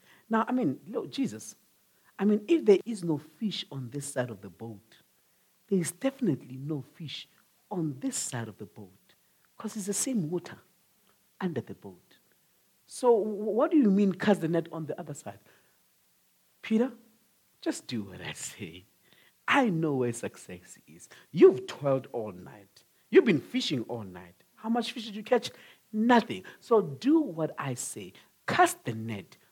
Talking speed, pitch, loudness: 170 wpm, 180 Hz, -29 LUFS